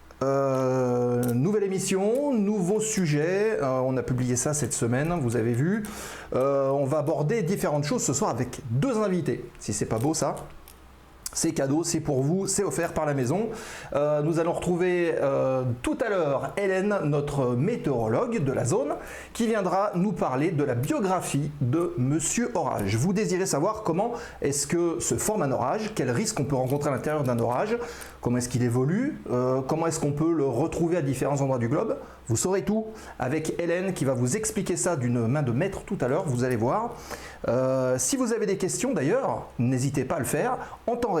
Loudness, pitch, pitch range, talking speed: -26 LUFS, 150 Hz, 130-185 Hz, 195 wpm